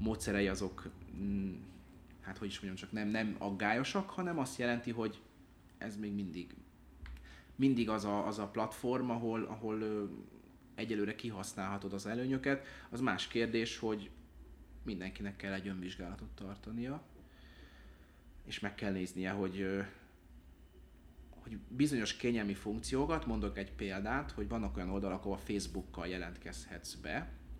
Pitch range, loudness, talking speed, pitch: 90-110 Hz, -39 LUFS, 130 wpm, 100 Hz